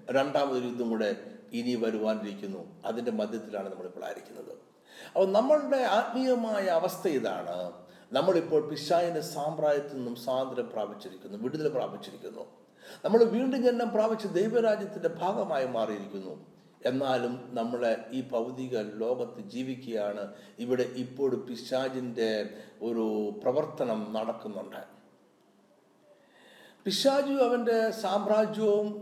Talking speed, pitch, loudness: 90 wpm, 130 Hz, -30 LUFS